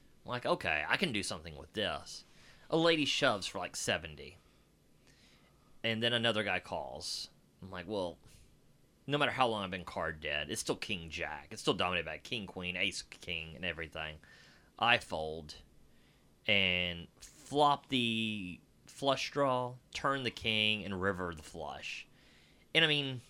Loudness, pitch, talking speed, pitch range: -34 LUFS, 105 Hz, 155 wpm, 85-125 Hz